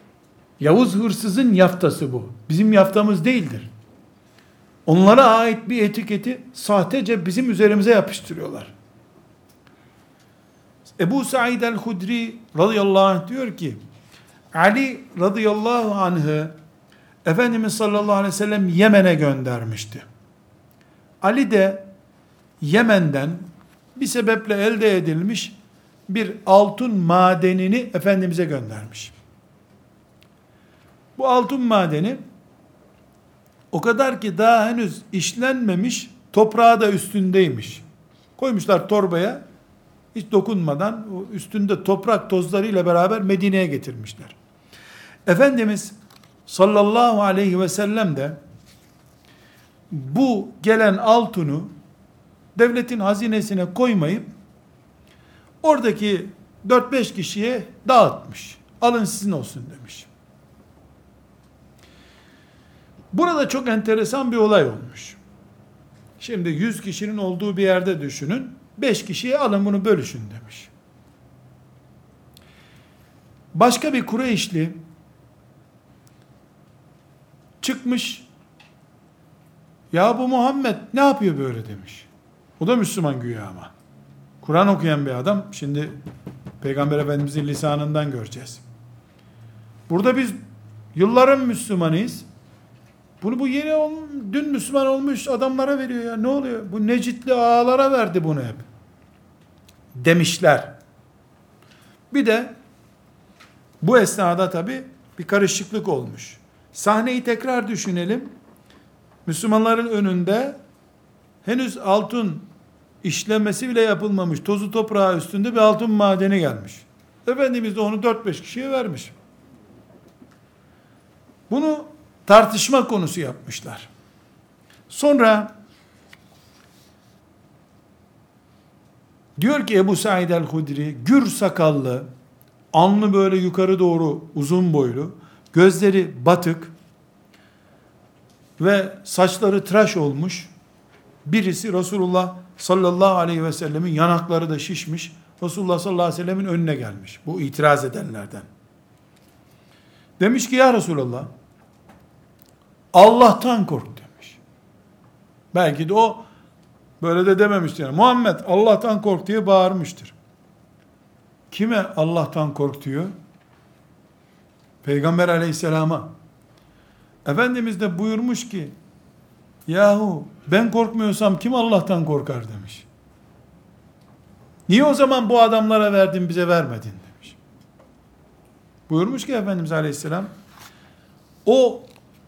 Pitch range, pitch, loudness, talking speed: 160-225 Hz, 195 Hz, -19 LUFS, 90 wpm